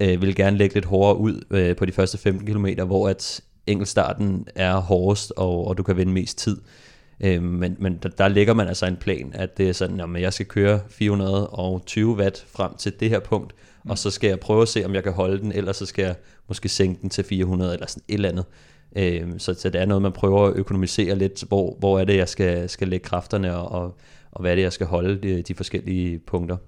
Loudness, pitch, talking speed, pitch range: -22 LUFS, 95 Hz, 230 wpm, 90-100 Hz